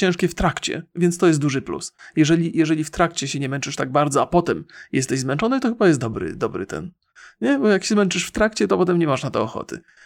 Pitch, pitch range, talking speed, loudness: 170 Hz, 145-185 Hz, 245 wpm, -21 LUFS